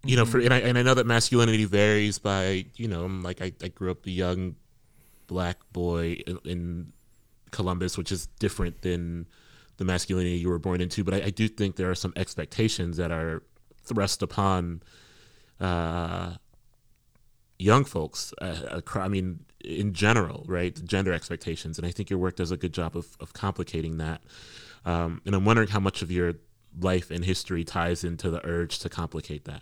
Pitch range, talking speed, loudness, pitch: 85-105 Hz, 190 wpm, -28 LUFS, 90 Hz